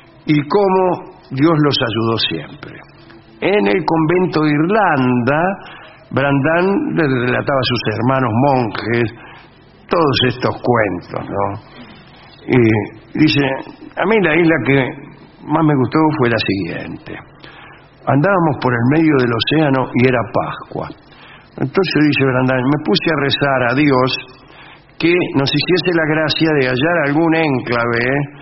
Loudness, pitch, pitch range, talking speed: -15 LUFS, 140 Hz, 125-160 Hz, 130 wpm